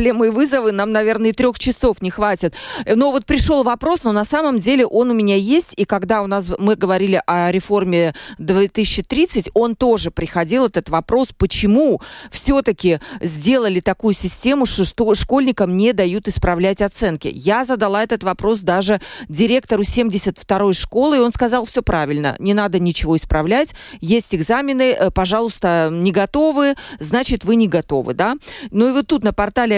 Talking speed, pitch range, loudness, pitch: 160 wpm, 190-245 Hz, -16 LUFS, 215 Hz